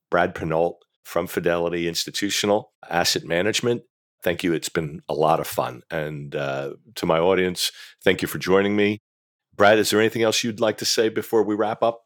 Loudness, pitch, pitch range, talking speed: -22 LUFS, 100 Hz, 85-110 Hz, 190 wpm